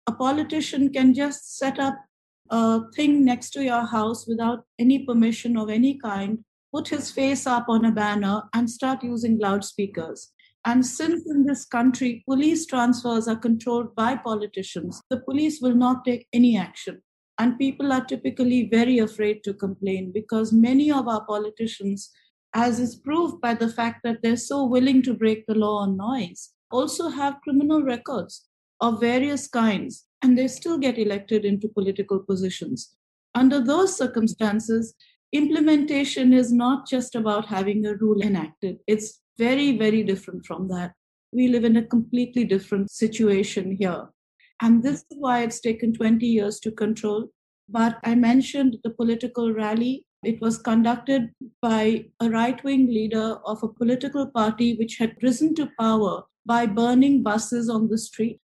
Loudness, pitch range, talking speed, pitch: -23 LUFS, 215-260 Hz, 160 wpm, 235 Hz